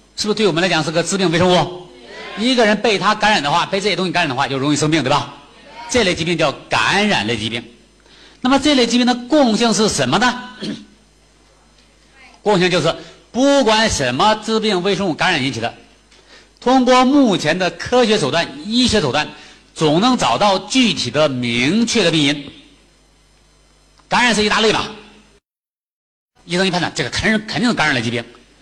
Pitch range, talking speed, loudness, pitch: 155-235 Hz, 275 characters per minute, -16 LUFS, 195 Hz